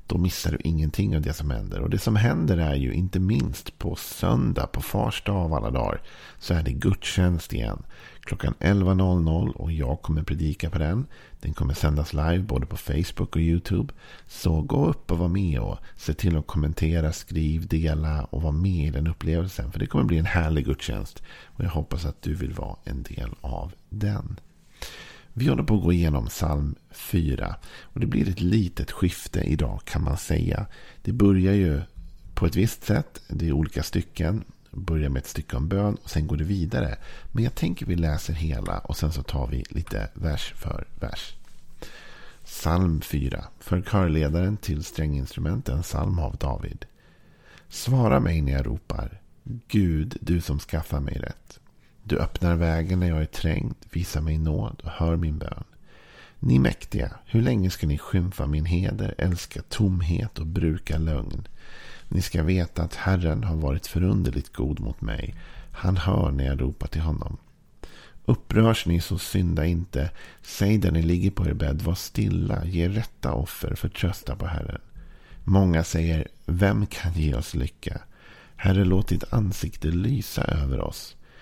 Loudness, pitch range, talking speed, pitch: -26 LUFS, 75-95 Hz, 175 wpm, 85 Hz